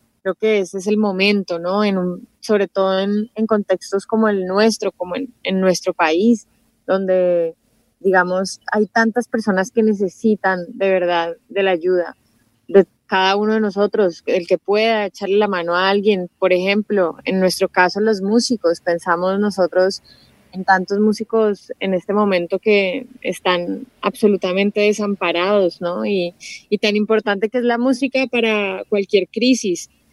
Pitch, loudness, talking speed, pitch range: 195 Hz, -18 LUFS, 155 wpm, 185-215 Hz